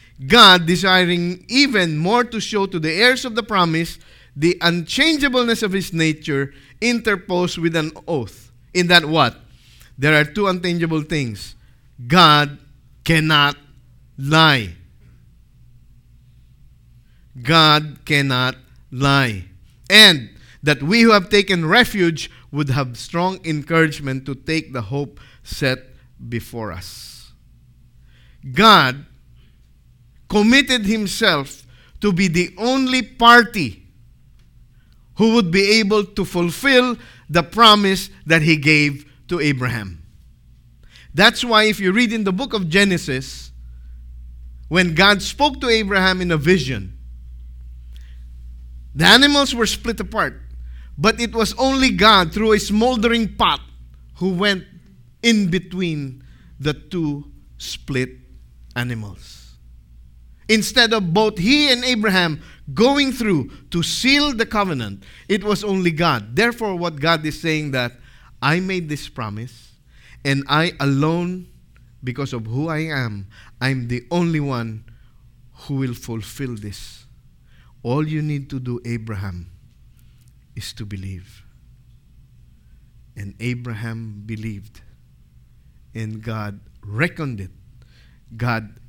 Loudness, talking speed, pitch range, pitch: -17 LUFS, 115 wpm, 115-185 Hz, 140 Hz